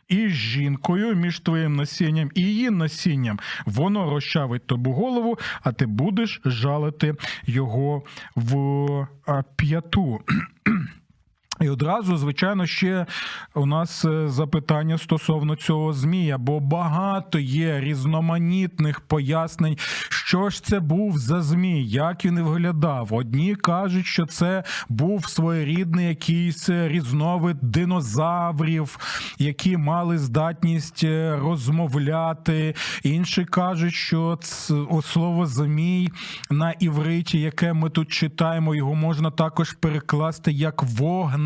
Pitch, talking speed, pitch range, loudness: 160 Hz, 110 wpm, 150-175 Hz, -23 LUFS